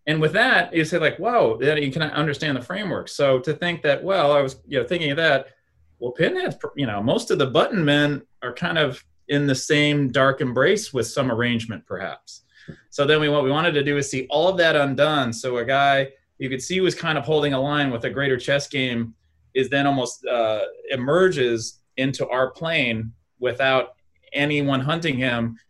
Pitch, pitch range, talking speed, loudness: 140 Hz, 130-150 Hz, 210 wpm, -21 LUFS